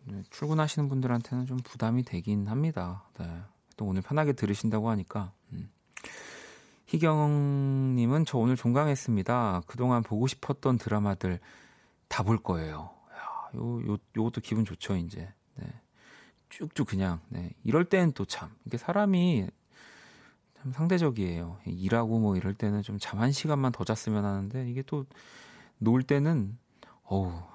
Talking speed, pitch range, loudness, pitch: 280 characters per minute, 100-135 Hz, -30 LUFS, 115 Hz